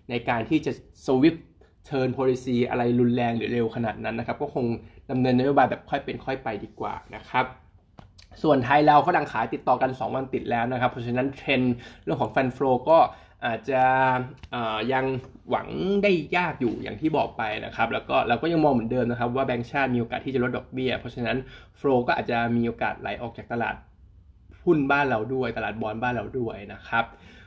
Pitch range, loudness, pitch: 115-130 Hz, -25 LUFS, 125 Hz